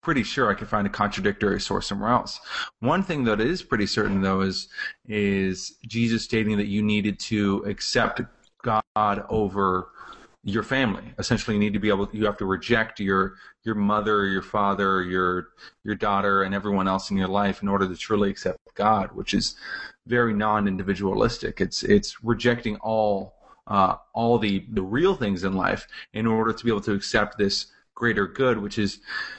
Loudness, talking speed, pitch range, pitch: -24 LUFS, 175 wpm, 100-110 Hz, 105 Hz